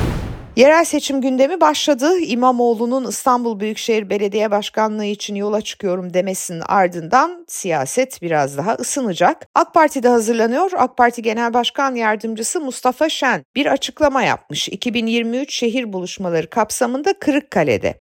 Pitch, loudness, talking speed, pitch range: 235 Hz, -17 LUFS, 125 wpm, 210-270 Hz